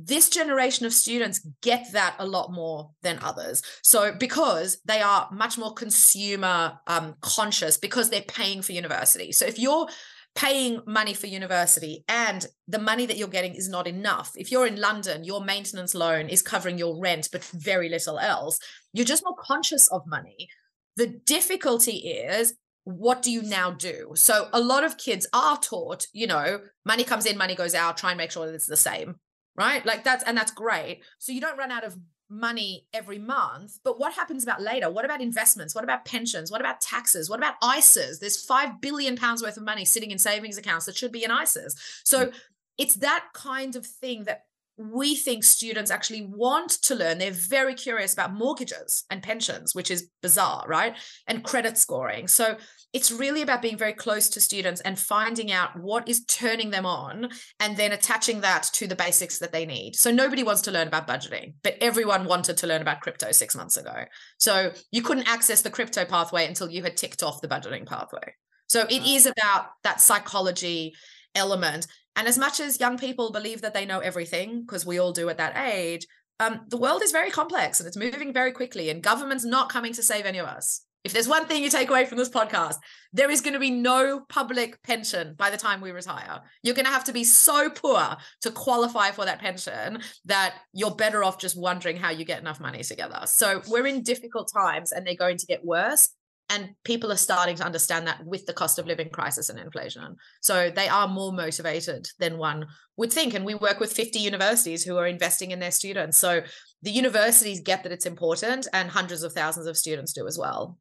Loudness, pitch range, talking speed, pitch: -23 LUFS, 180-245 Hz, 210 wpm, 210 Hz